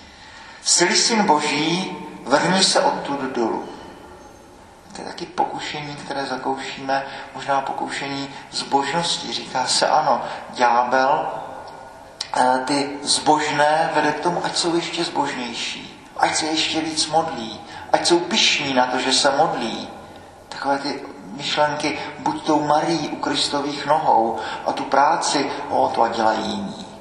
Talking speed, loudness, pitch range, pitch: 130 wpm, -20 LUFS, 140-160 Hz, 150 Hz